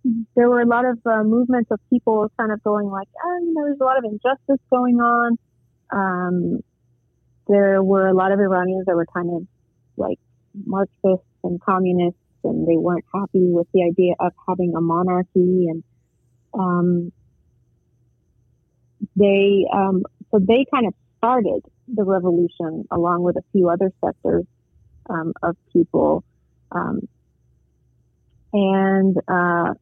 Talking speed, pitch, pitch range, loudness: 145 wpm, 185 Hz, 170-215 Hz, -20 LUFS